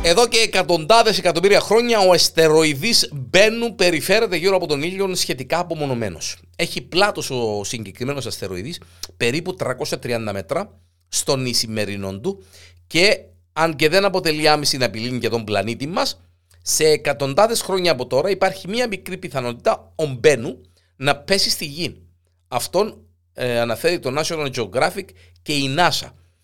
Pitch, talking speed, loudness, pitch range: 145 Hz, 140 wpm, -19 LUFS, 110-180 Hz